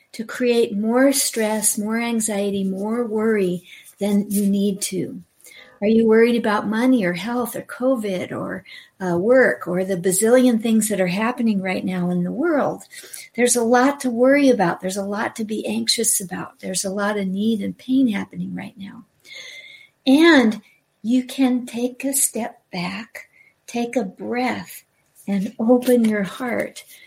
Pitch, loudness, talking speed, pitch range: 225 Hz, -20 LUFS, 160 wpm, 200-250 Hz